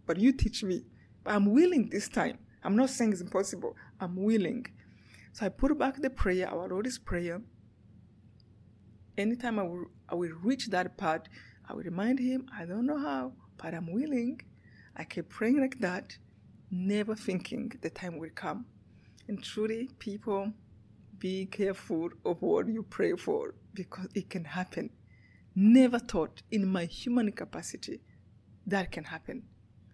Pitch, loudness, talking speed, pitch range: 195 Hz, -32 LUFS, 155 wpm, 170-235 Hz